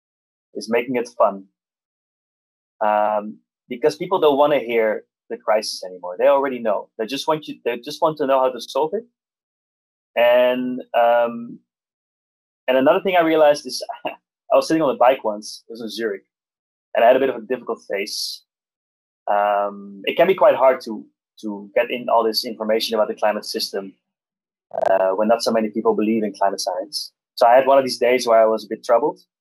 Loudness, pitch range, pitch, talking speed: -19 LUFS, 105-135 Hz, 115 Hz, 200 wpm